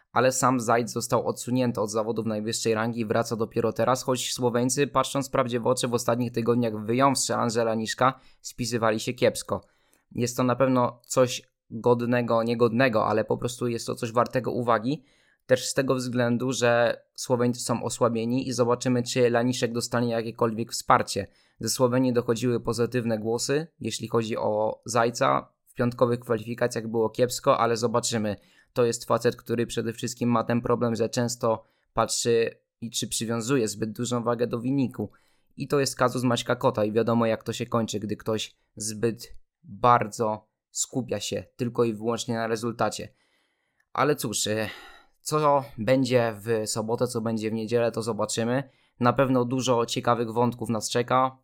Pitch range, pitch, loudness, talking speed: 115-125 Hz, 120 Hz, -26 LUFS, 160 wpm